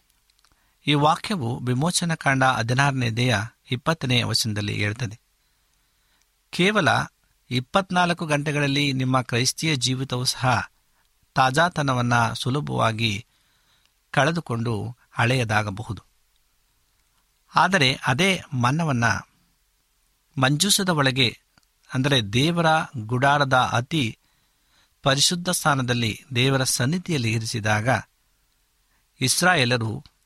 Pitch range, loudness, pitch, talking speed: 120-150 Hz, -22 LUFS, 130 Hz, 70 wpm